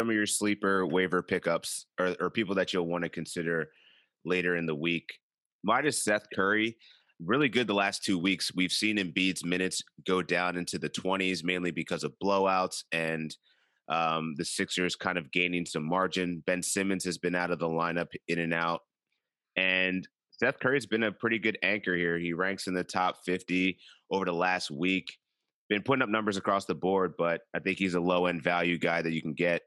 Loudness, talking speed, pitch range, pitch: -30 LUFS, 200 wpm, 85-95 Hz, 90 Hz